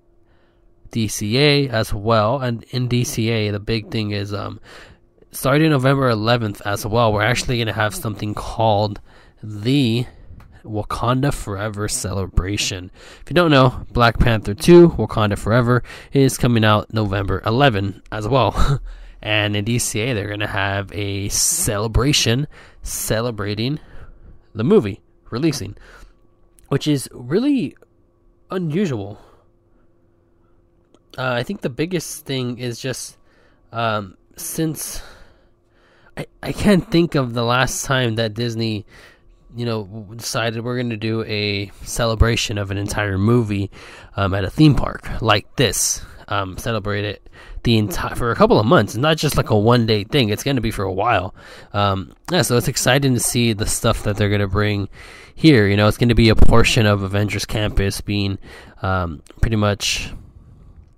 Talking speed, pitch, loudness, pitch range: 150 wpm, 110 Hz, -19 LUFS, 100-125 Hz